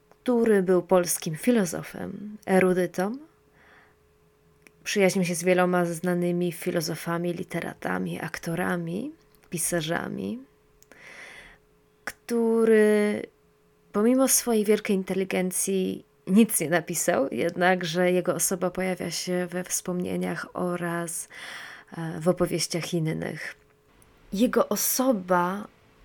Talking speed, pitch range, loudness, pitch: 80 wpm, 175-205 Hz, -25 LUFS, 180 Hz